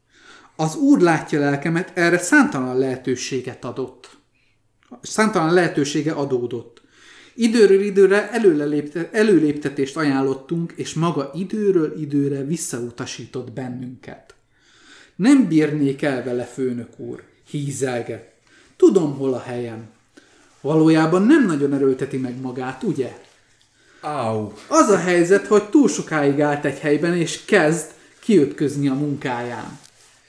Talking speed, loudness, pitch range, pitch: 105 wpm, -19 LUFS, 130-170 Hz, 145 Hz